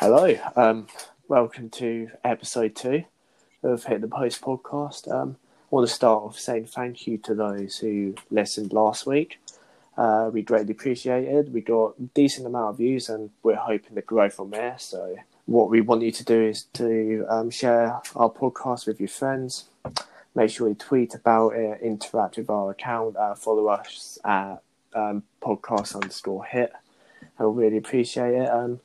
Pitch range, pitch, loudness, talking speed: 110-125 Hz, 115 Hz, -25 LUFS, 175 wpm